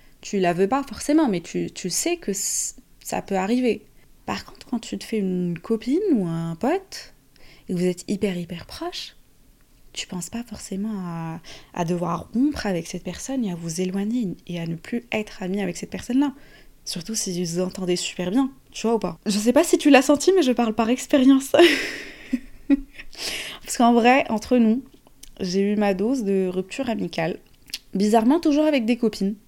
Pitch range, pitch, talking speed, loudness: 185-265 Hz, 215 Hz, 195 wpm, -23 LUFS